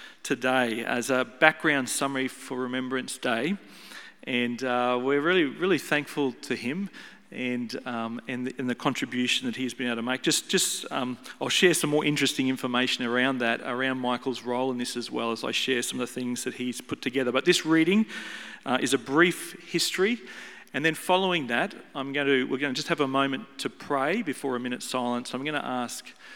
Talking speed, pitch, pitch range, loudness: 205 wpm, 130 Hz, 125-150 Hz, -27 LUFS